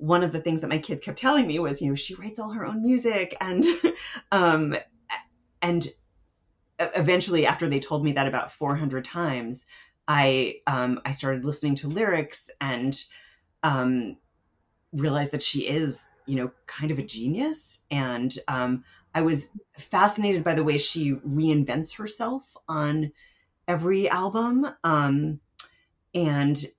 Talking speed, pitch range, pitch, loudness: 150 wpm, 135-180 Hz, 150 Hz, -26 LUFS